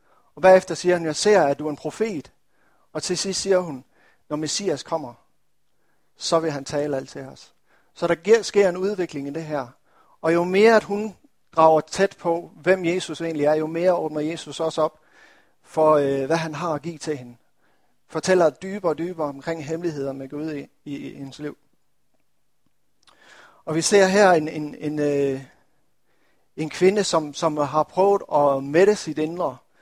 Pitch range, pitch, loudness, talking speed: 150-180 Hz, 160 Hz, -22 LUFS, 185 wpm